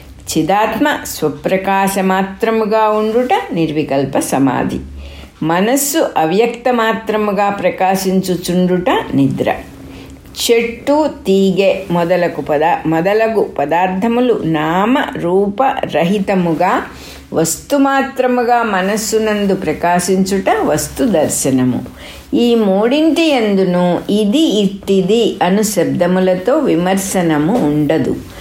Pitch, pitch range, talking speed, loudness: 195 Hz, 170-225 Hz, 65 wpm, -14 LUFS